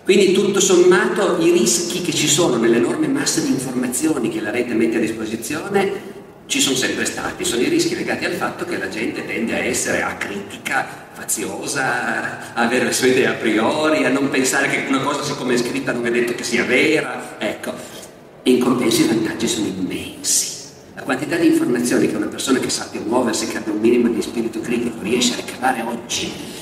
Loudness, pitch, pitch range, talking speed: -18 LUFS, 155 Hz, 125-195 Hz, 195 wpm